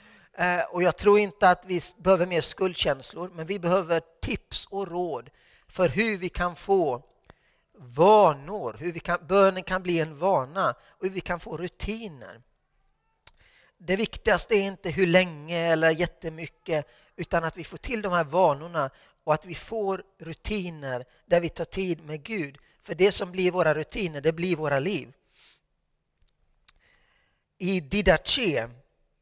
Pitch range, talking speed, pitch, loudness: 165-190 Hz, 150 wpm, 175 Hz, -26 LUFS